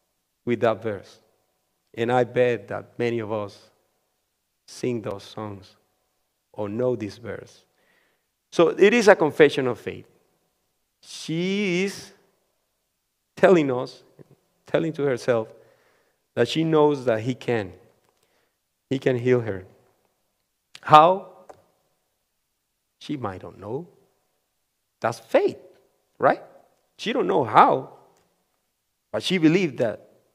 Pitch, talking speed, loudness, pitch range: 125 Hz, 115 wpm, -22 LUFS, 110-155 Hz